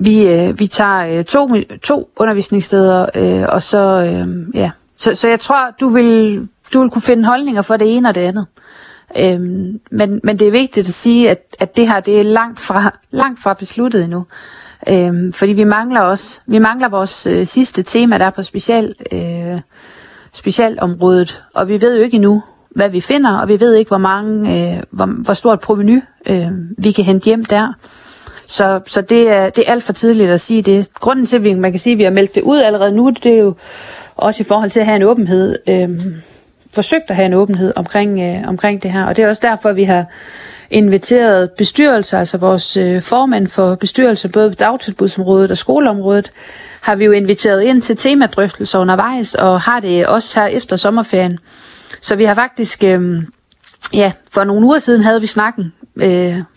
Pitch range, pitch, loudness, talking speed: 190-230 Hz, 205 Hz, -12 LUFS, 205 wpm